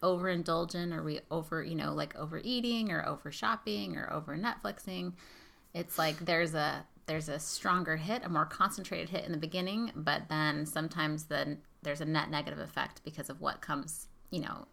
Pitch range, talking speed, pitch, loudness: 155-185 Hz, 180 wpm, 165 Hz, -35 LUFS